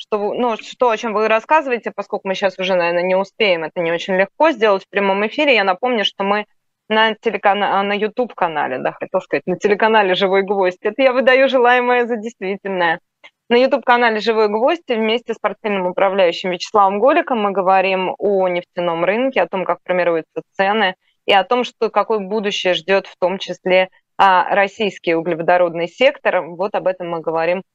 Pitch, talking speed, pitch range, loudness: 200 Hz, 175 wpm, 185-225 Hz, -17 LUFS